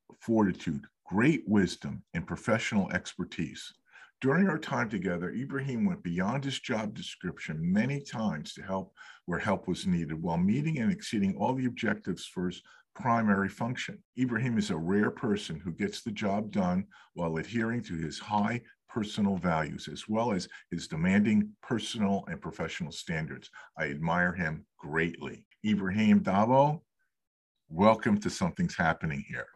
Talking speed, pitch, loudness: 145 wpm, 120 Hz, -31 LUFS